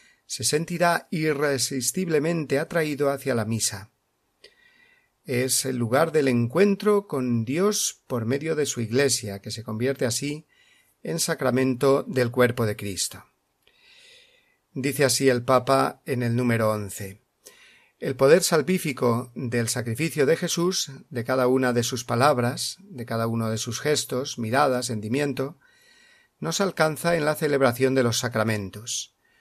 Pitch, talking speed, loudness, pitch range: 135 Hz, 135 wpm, -24 LUFS, 120-165 Hz